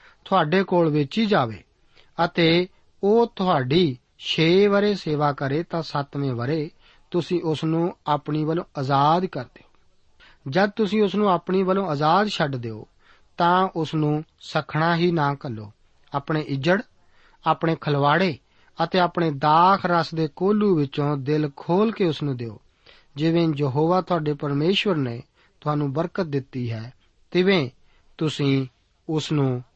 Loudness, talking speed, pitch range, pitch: -22 LUFS, 135 wpm, 145-180 Hz, 160 Hz